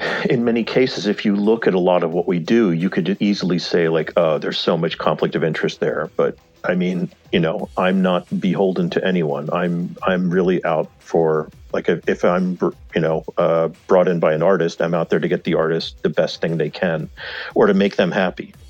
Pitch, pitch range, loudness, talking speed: 90 Hz, 85-100 Hz, -19 LUFS, 220 wpm